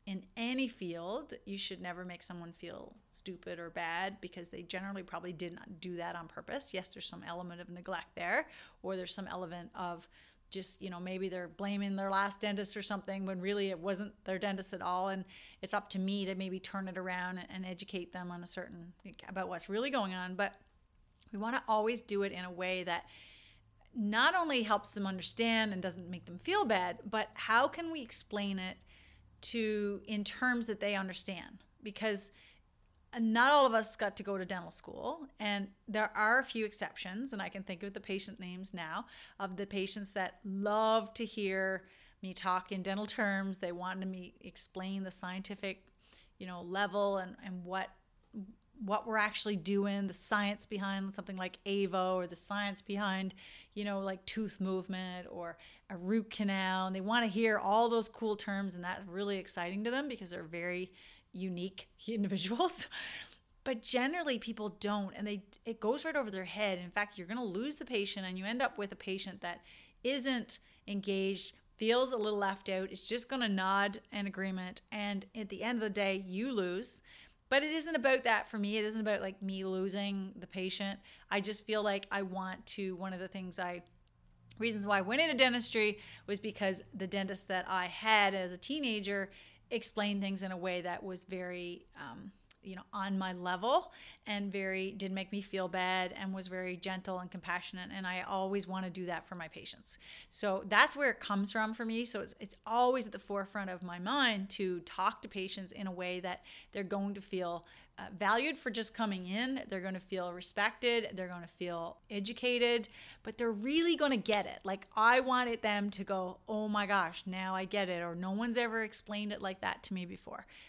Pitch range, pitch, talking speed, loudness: 185-215 Hz, 195 Hz, 200 wpm, -36 LUFS